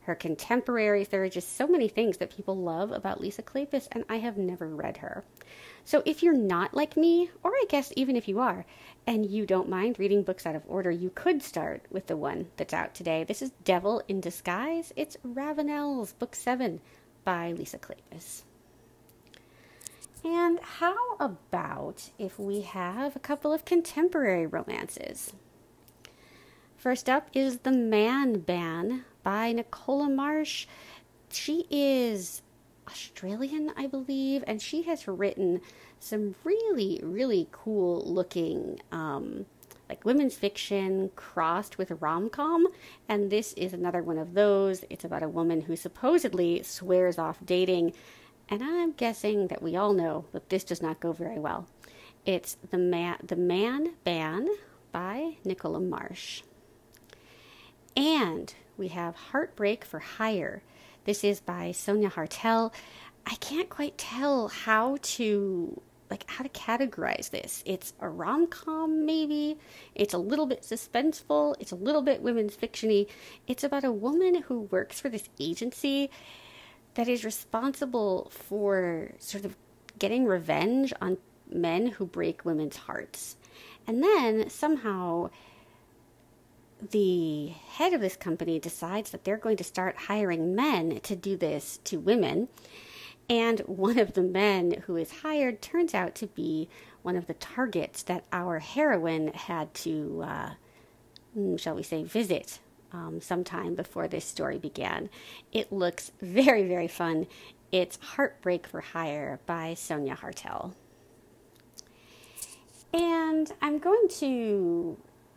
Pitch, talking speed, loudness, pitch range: 205 Hz, 140 wpm, -30 LUFS, 175-270 Hz